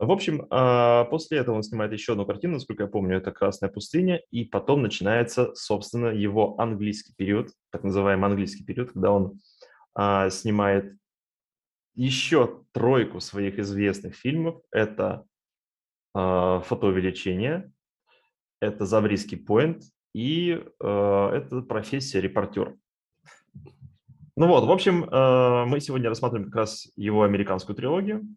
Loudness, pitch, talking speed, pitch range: -25 LUFS, 110 Hz, 115 wpm, 100-130 Hz